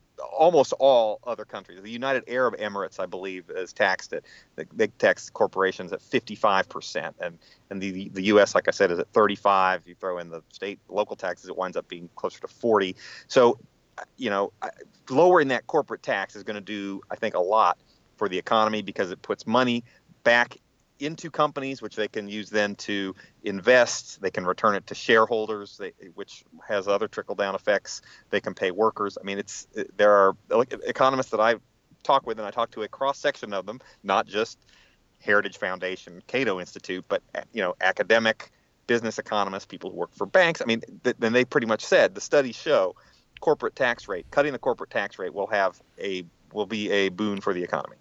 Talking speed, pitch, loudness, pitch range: 190 wpm, 105 Hz, -25 LUFS, 95-120 Hz